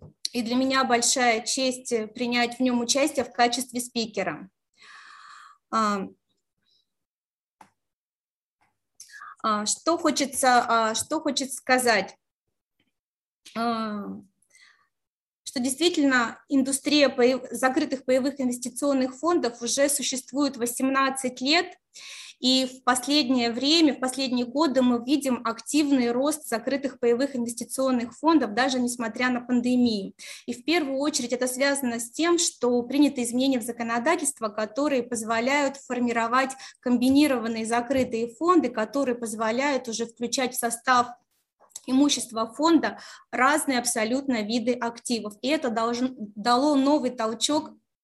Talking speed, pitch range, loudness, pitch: 105 wpm, 235-275 Hz, -24 LUFS, 255 Hz